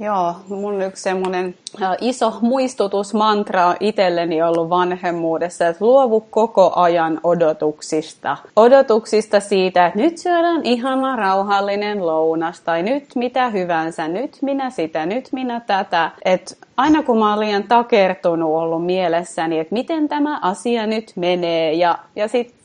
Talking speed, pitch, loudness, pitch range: 135 wpm, 195 Hz, -18 LUFS, 170-235 Hz